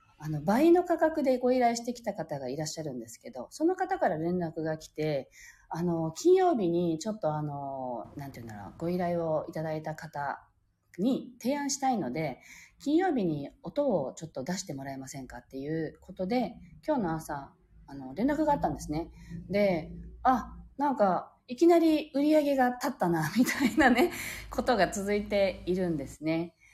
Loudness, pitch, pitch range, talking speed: -30 LUFS, 175 Hz, 155-255 Hz, 340 characters per minute